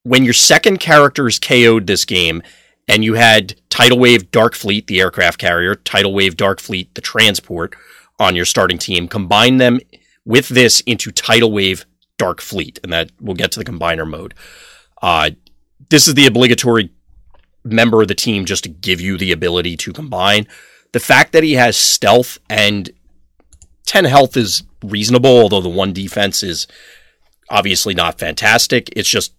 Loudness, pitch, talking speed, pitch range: -12 LUFS, 105 Hz, 170 wpm, 90-125 Hz